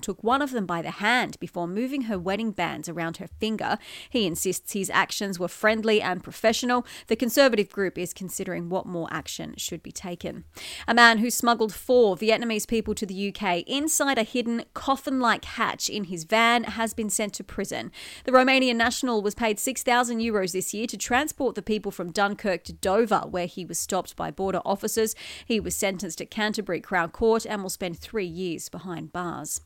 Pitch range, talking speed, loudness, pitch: 185-230 Hz, 195 wpm, -25 LUFS, 210 Hz